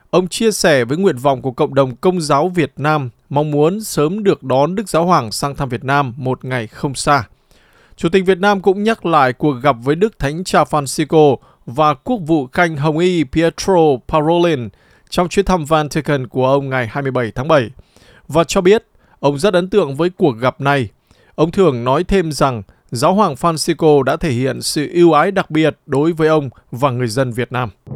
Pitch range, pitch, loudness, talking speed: 135-175 Hz, 150 Hz, -15 LUFS, 205 wpm